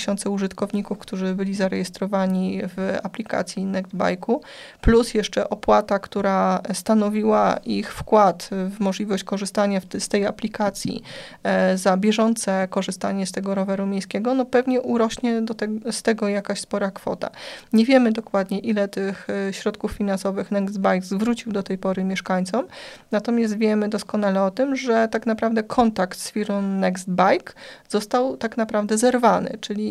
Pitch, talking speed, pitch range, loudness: 205 Hz, 140 wpm, 195-225 Hz, -22 LUFS